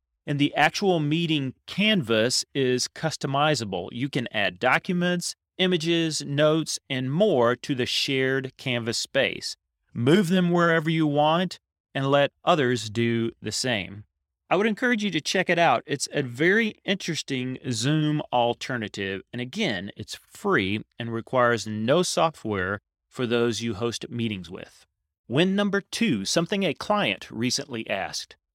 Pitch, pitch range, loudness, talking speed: 135 Hz, 115-170 Hz, -25 LUFS, 140 wpm